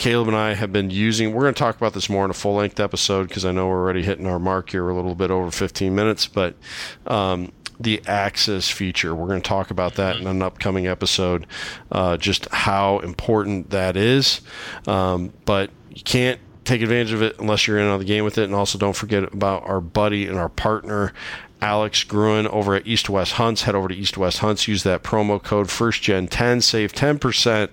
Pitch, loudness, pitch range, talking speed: 100 Hz, -21 LUFS, 95-110 Hz, 225 wpm